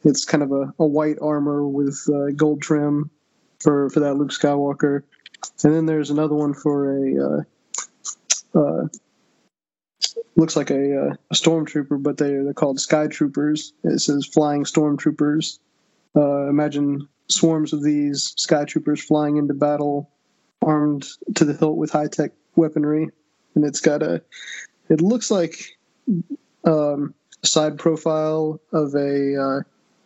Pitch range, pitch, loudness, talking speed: 145-155 Hz, 150 Hz, -21 LUFS, 145 wpm